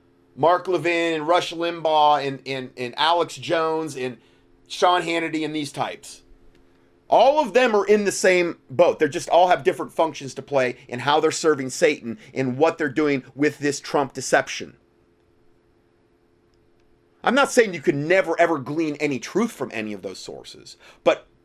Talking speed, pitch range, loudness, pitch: 170 wpm, 105-165 Hz, -21 LUFS, 145 Hz